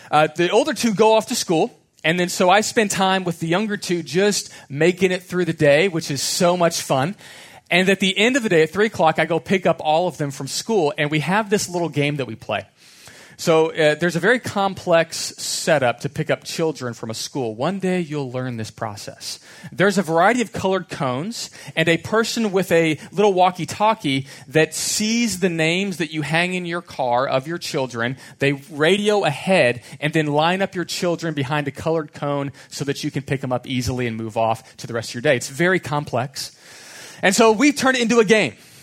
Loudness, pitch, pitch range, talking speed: -20 LUFS, 165 Hz, 140-190 Hz, 225 wpm